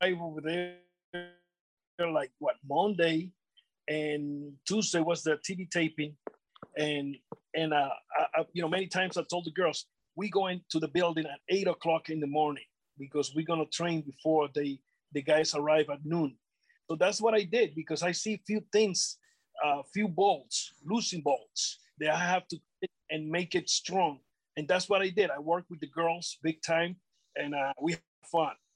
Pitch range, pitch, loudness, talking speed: 155-185 Hz, 165 Hz, -31 LUFS, 180 wpm